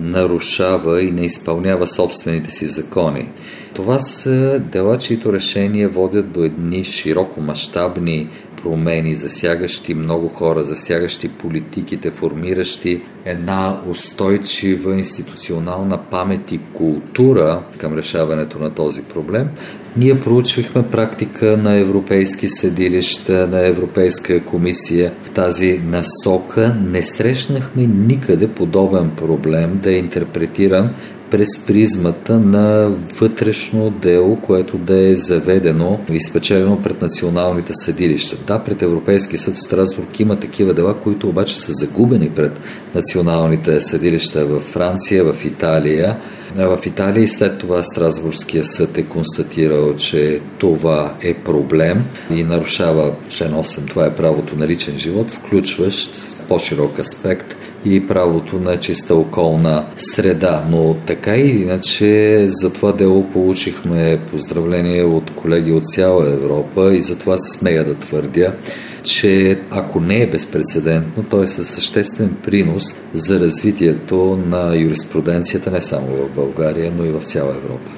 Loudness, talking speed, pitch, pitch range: -16 LUFS, 125 wpm, 90 Hz, 80-95 Hz